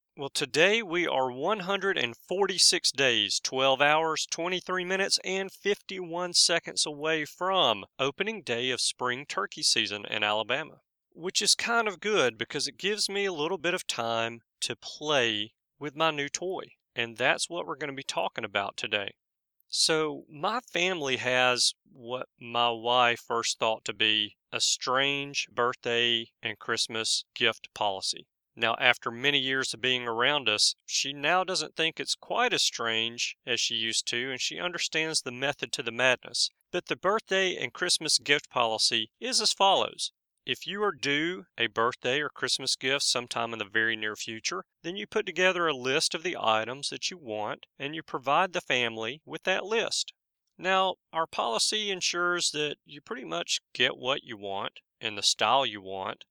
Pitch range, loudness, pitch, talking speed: 120-180 Hz, -27 LUFS, 140 Hz, 170 wpm